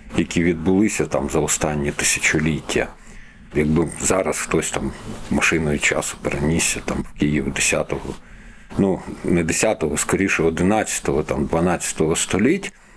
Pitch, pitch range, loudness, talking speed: 80 Hz, 75-90 Hz, -20 LUFS, 115 wpm